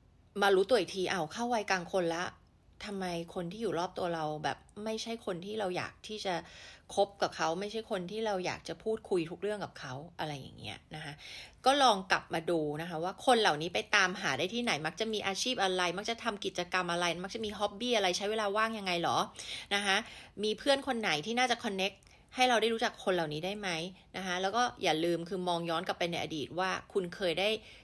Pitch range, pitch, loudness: 175-220 Hz, 195 Hz, -33 LUFS